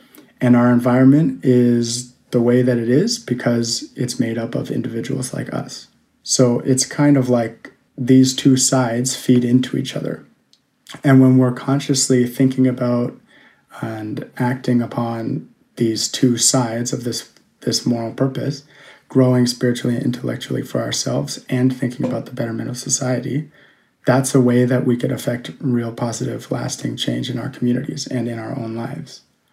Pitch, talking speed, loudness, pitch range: 125 Hz, 160 wpm, -18 LUFS, 120-135 Hz